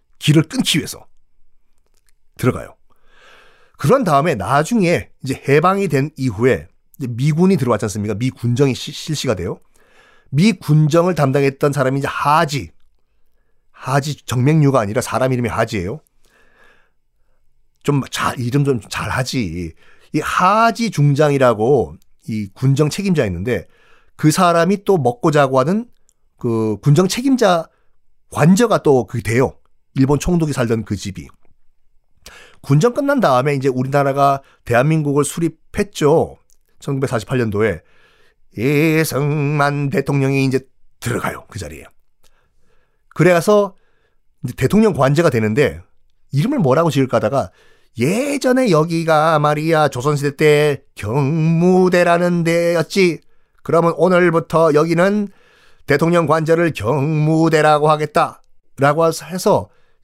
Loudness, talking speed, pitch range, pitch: -16 LUFS, 260 characters per minute, 130-165 Hz, 145 Hz